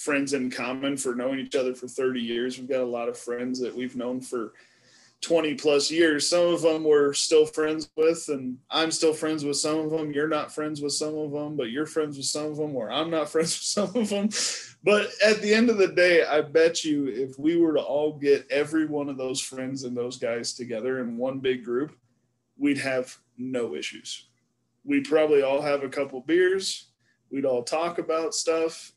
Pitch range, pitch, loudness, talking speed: 130-160 Hz, 145 Hz, -25 LUFS, 220 wpm